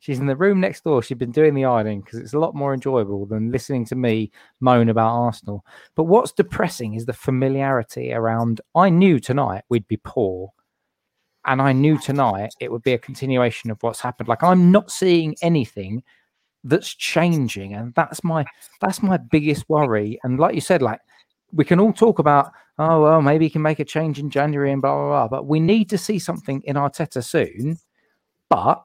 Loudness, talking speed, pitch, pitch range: -20 LUFS, 205 wpm, 135 Hz, 120-160 Hz